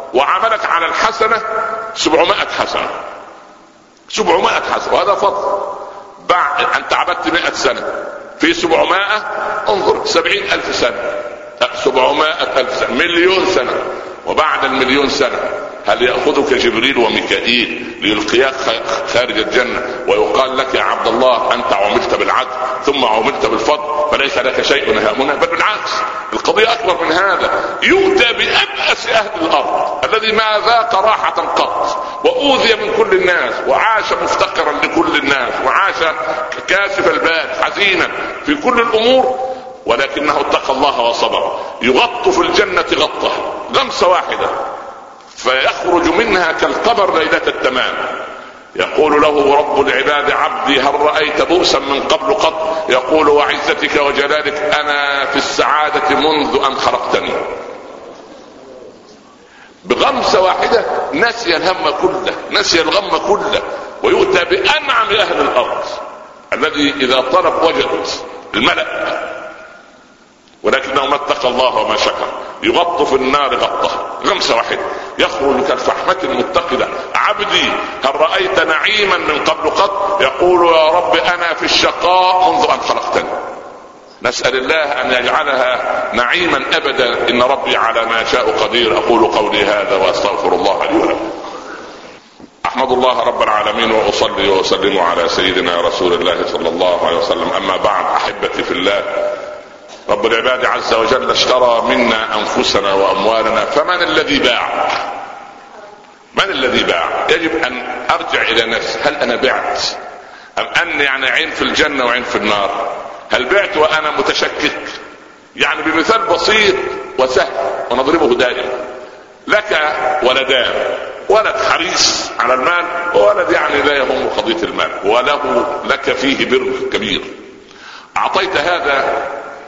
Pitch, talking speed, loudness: 220 Hz, 120 wpm, -13 LUFS